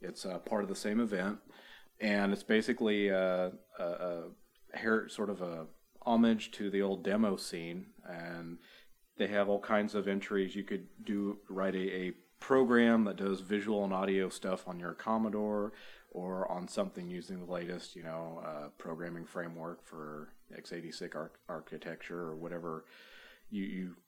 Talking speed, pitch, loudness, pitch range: 160 wpm, 95 Hz, -35 LUFS, 85-105 Hz